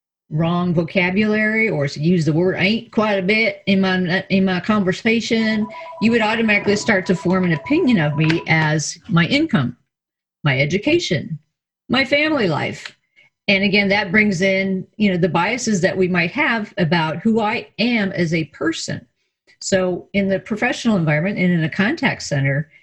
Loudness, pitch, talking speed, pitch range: -18 LUFS, 195 Hz, 170 wpm, 175-220 Hz